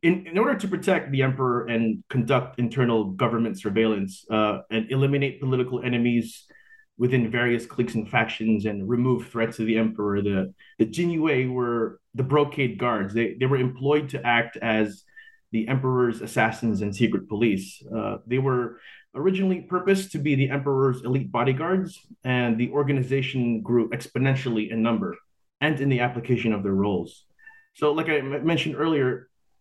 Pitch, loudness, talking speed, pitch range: 125 Hz, -24 LUFS, 160 wpm, 115-145 Hz